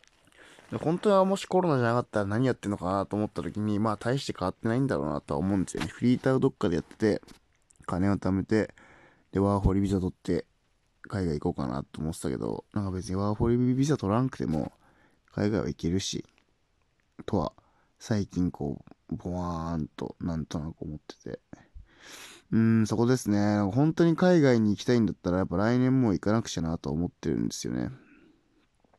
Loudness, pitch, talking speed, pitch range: -28 LUFS, 100 Hz, 390 characters per minute, 90-120 Hz